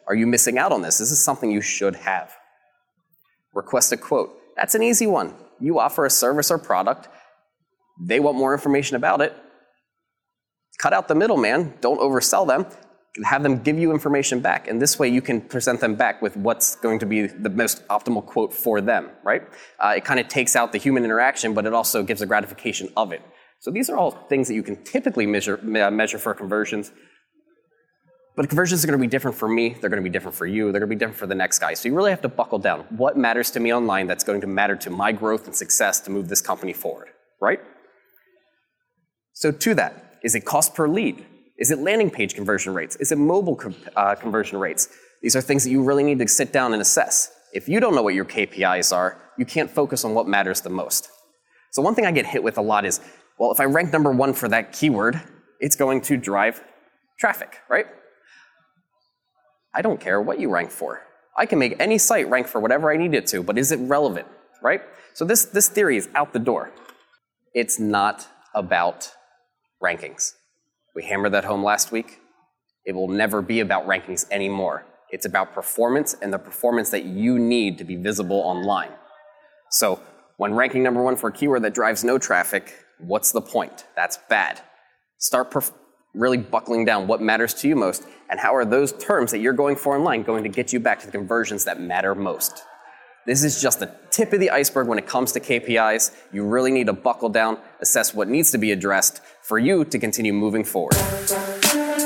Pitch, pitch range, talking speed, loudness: 125 Hz, 110-150 Hz, 210 wpm, -21 LUFS